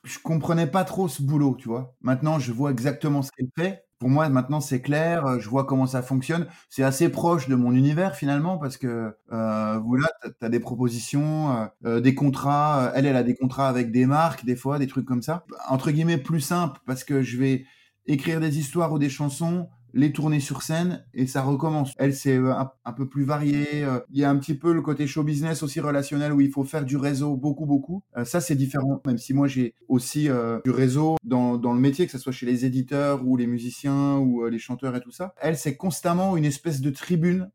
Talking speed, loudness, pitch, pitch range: 225 wpm, -24 LUFS, 140 Hz, 130-155 Hz